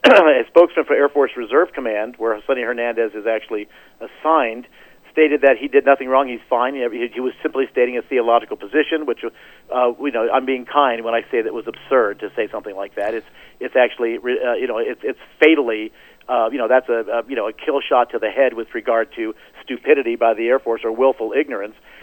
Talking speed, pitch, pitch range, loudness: 220 wpm, 130 Hz, 115-155 Hz, -18 LUFS